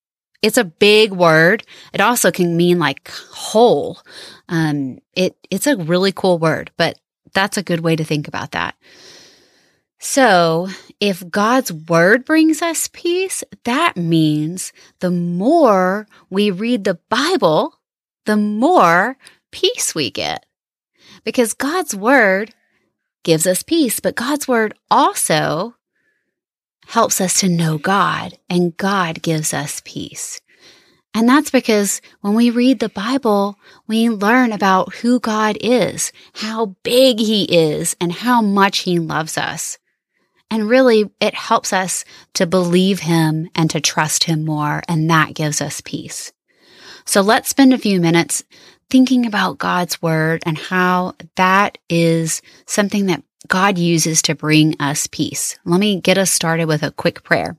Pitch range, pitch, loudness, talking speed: 170-230 Hz, 195 Hz, -16 LUFS, 145 wpm